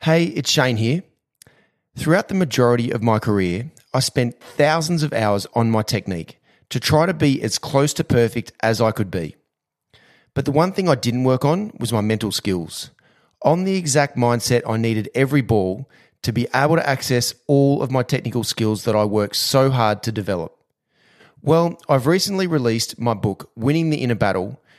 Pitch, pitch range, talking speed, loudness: 120 Hz, 110-150 Hz, 185 wpm, -19 LUFS